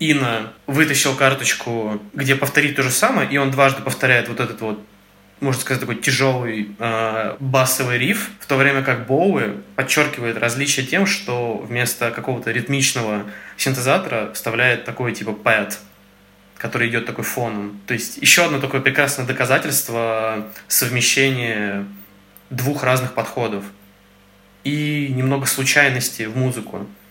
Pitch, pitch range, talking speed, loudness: 125 Hz, 110-135 Hz, 130 wpm, -18 LUFS